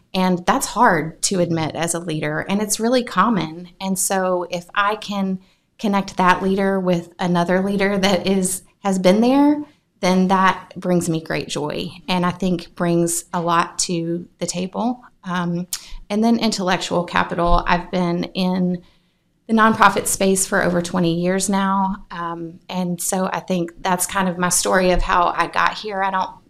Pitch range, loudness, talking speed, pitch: 175-195 Hz, -19 LUFS, 170 wpm, 185 Hz